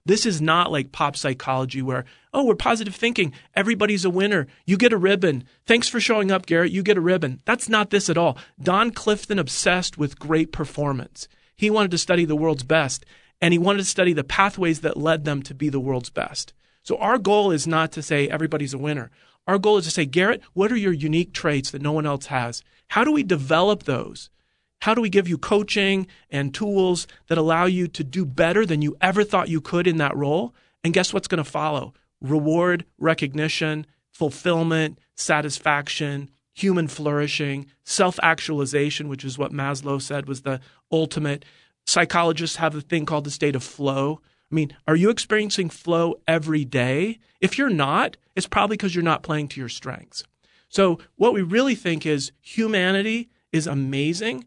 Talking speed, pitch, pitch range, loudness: 190 wpm, 165 Hz, 145-195 Hz, -22 LUFS